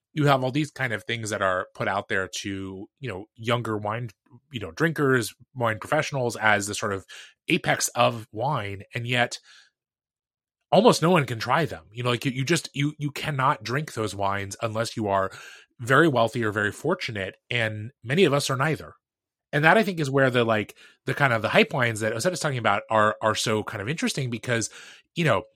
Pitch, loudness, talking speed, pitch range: 120 Hz, -24 LUFS, 215 wpm, 110-145 Hz